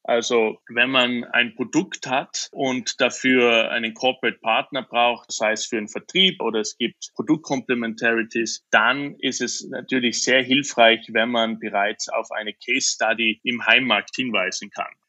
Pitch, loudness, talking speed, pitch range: 120 Hz, -21 LUFS, 150 wpm, 115-130 Hz